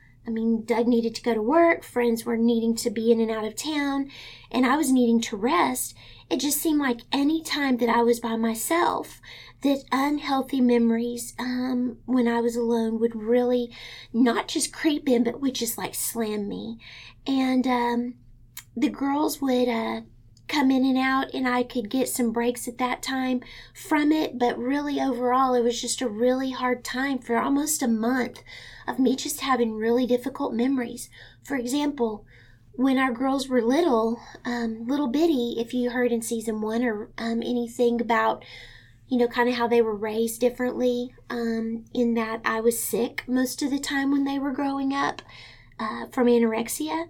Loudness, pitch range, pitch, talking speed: -25 LUFS, 230-265 Hz, 245 Hz, 180 wpm